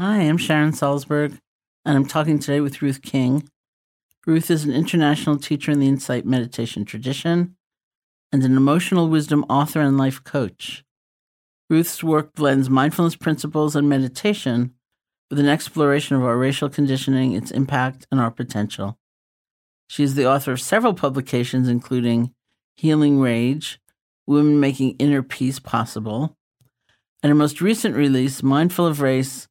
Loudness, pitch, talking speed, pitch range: -20 LUFS, 140 Hz, 145 wpm, 130-150 Hz